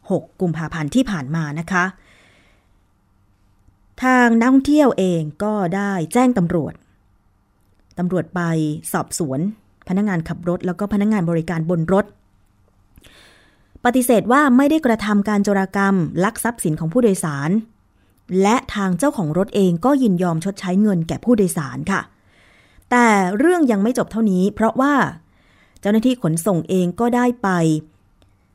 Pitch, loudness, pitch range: 185 Hz, -18 LUFS, 150-215 Hz